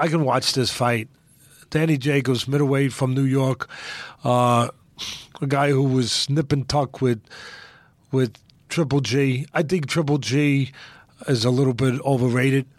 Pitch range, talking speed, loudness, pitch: 130-145 Hz, 145 wpm, -22 LUFS, 135 Hz